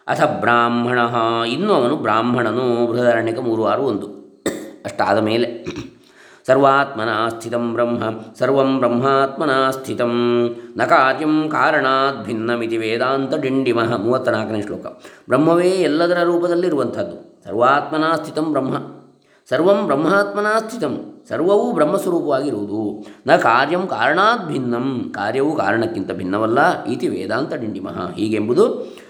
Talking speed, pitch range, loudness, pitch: 95 wpm, 120-155 Hz, -18 LUFS, 125 Hz